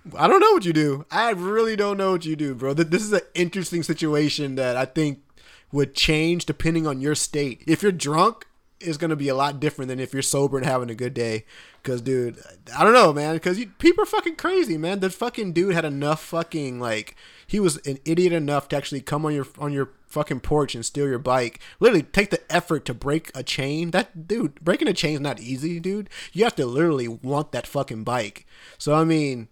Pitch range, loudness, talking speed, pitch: 135-175 Hz, -23 LUFS, 230 wpm, 150 Hz